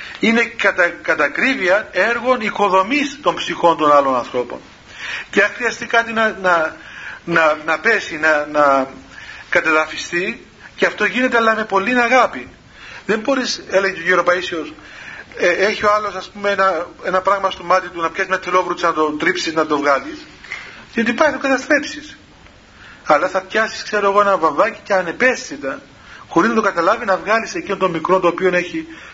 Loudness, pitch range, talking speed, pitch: -17 LUFS, 170-230 Hz, 165 wpm, 195 Hz